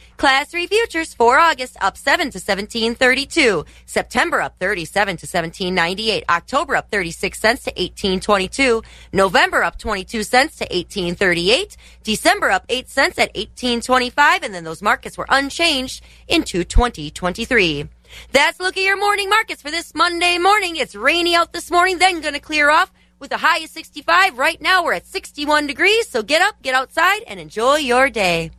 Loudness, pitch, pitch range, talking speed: -17 LUFS, 260 Hz, 200-330 Hz, 165 wpm